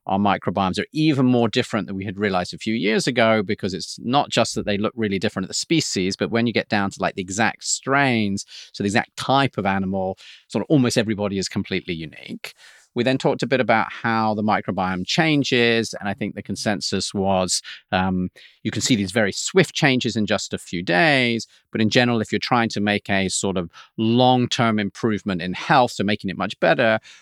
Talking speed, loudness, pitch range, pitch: 220 wpm, -21 LUFS, 100-125 Hz, 110 Hz